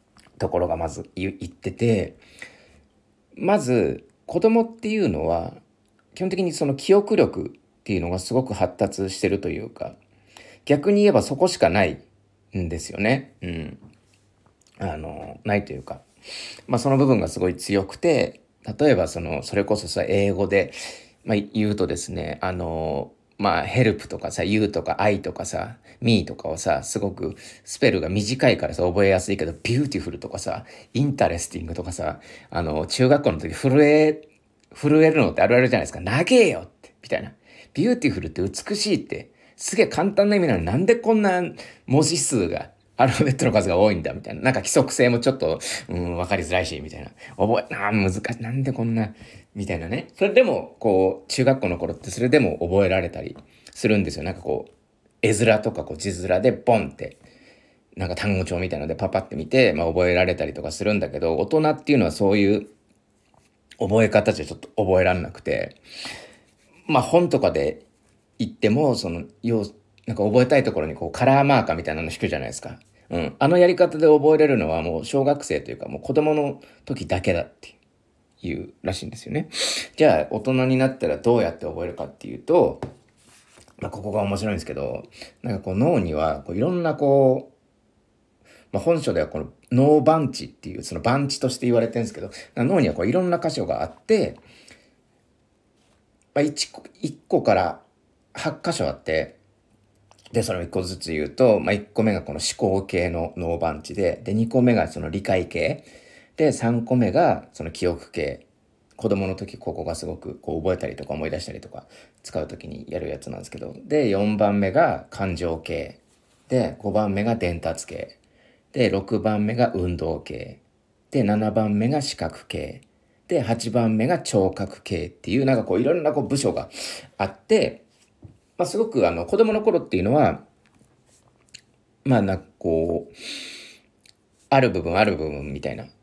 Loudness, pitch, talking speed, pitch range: -22 LUFS, 105 Hz, 350 characters per minute, 90-135 Hz